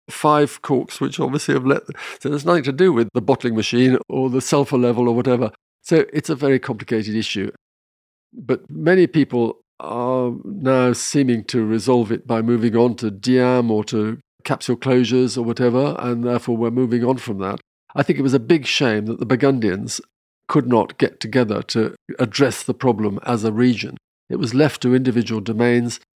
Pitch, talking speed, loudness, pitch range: 125 Hz, 190 wpm, -19 LUFS, 115-130 Hz